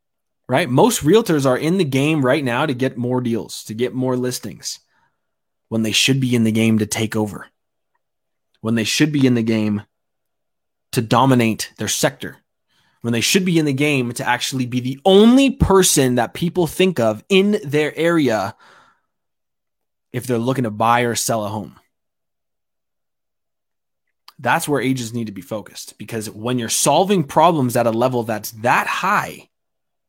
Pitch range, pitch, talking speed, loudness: 110-145 Hz, 125 Hz, 170 wpm, -18 LUFS